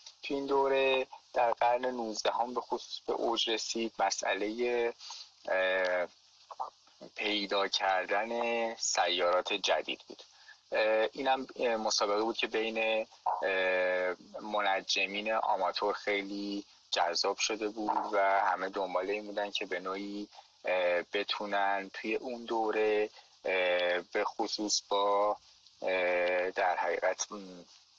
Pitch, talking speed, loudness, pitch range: 105 Hz, 100 wpm, -32 LUFS, 95-110 Hz